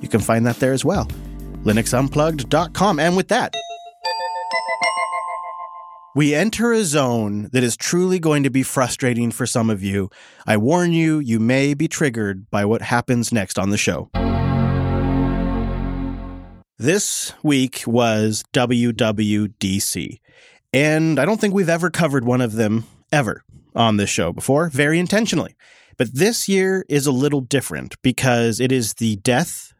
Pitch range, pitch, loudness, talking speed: 115-165 Hz, 130 Hz, -19 LUFS, 145 wpm